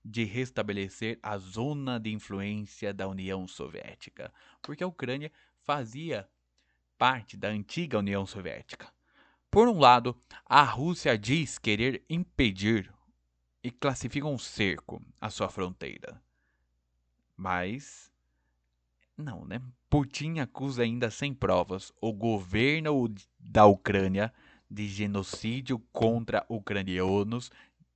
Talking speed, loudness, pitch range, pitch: 105 wpm, -29 LUFS, 95-130 Hz, 110 Hz